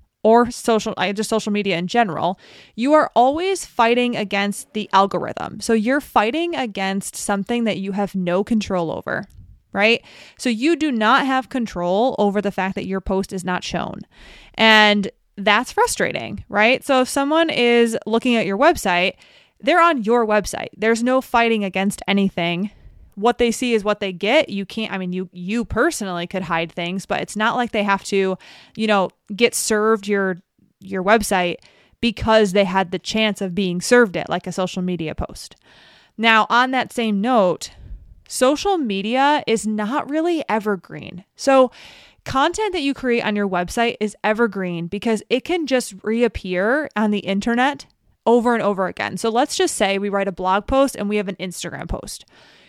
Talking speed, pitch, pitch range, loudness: 175 wpm, 215 Hz, 195-240 Hz, -19 LUFS